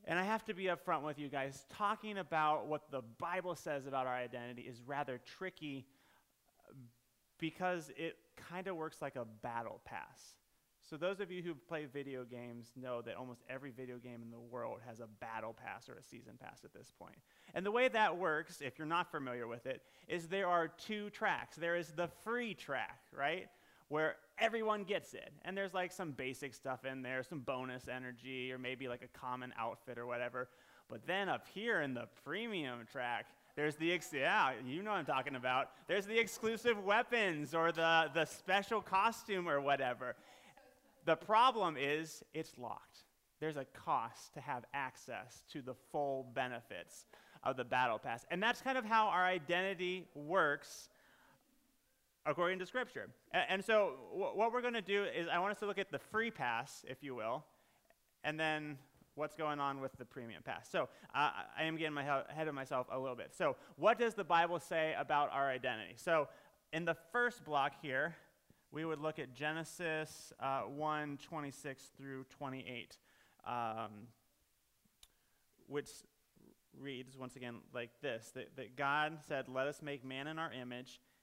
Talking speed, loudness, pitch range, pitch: 185 wpm, -40 LUFS, 130-180 Hz, 150 Hz